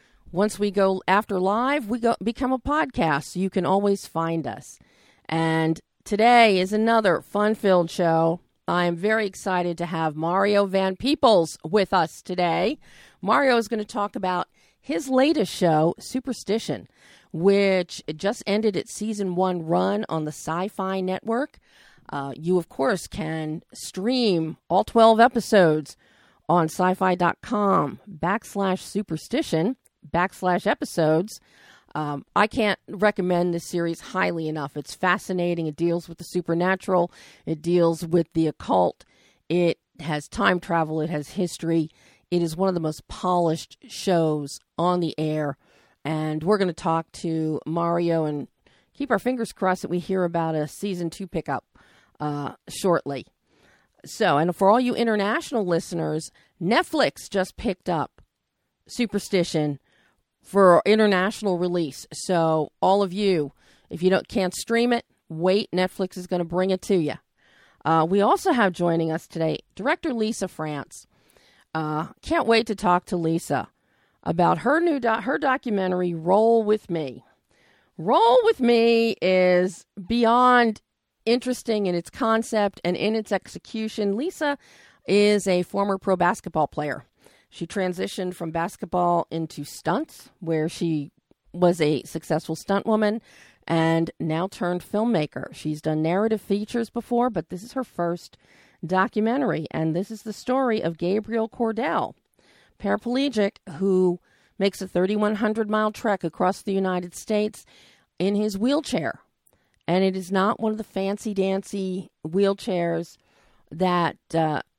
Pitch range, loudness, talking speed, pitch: 165-215 Hz, -24 LUFS, 145 wpm, 185 Hz